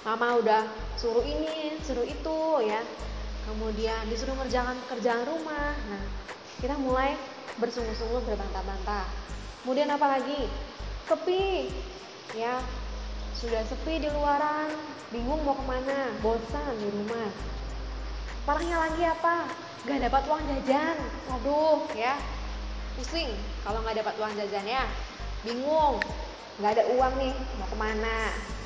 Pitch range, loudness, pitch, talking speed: 225-295 Hz, -30 LUFS, 255 Hz, 115 wpm